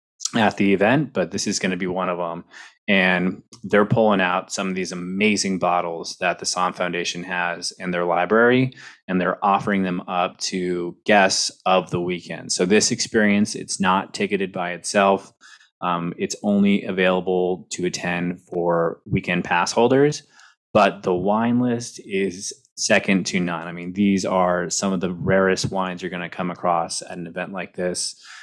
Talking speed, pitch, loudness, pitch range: 175 wpm, 95 Hz, -21 LUFS, 90-100 Hz